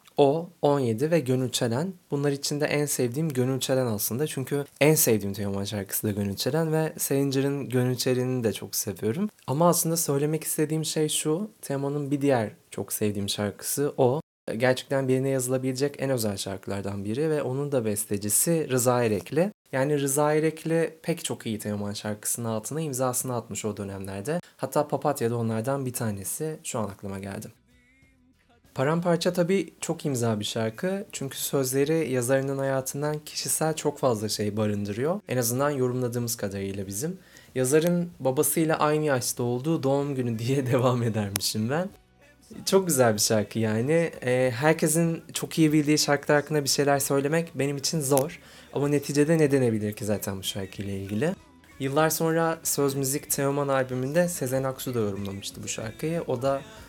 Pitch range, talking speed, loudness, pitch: 115-155 Hz, 155 wpm, -26 LUFS, 135 Hz